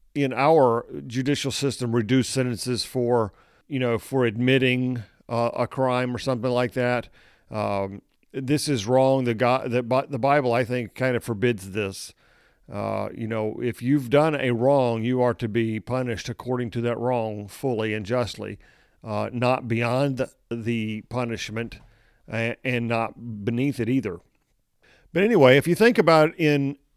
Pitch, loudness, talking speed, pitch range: 125 Hz, -24 LUFS, 160 wpm, 115-130 Hz